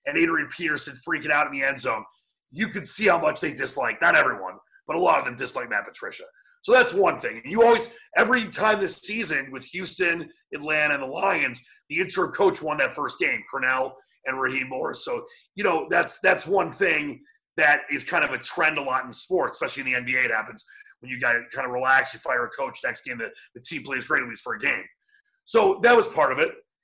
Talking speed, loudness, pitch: 235 wpm, -23 LUFS, 215 Hz